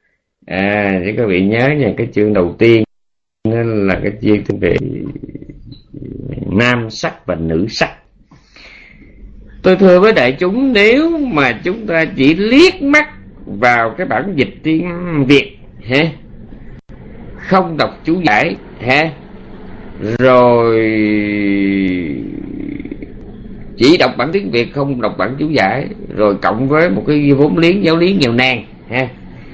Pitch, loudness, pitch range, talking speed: 130 Hz, -13 LUFS, 105-160 Hz, 135 wpm